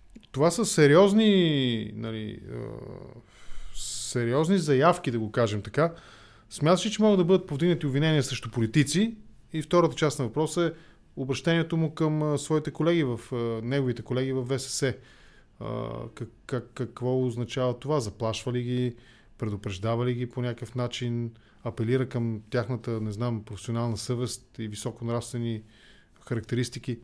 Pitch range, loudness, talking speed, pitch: 115-150 Hz, -27 LUFS, 130 wpm, 125 Hz